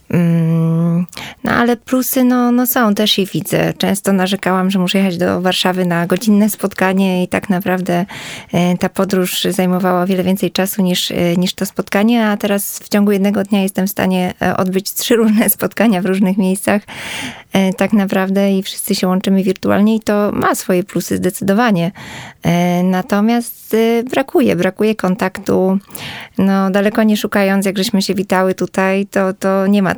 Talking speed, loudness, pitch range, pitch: 155 wpm, -15 LUFS, 185-210 Hz, 195 Hz